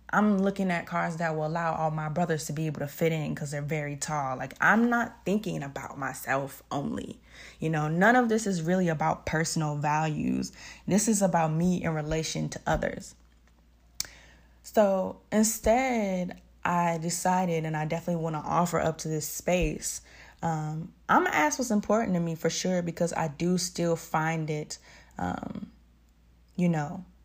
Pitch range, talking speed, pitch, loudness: 150-180 Hz, 170 wpm, 165 Hz, -28 LUFS